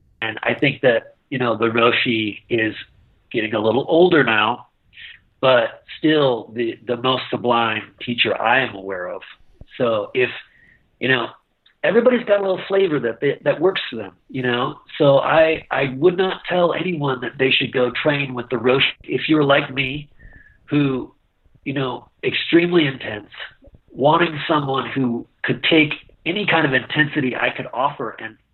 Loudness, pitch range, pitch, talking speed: -19 LUFS, 120-160 Hz, 135 Hz, 165 wpm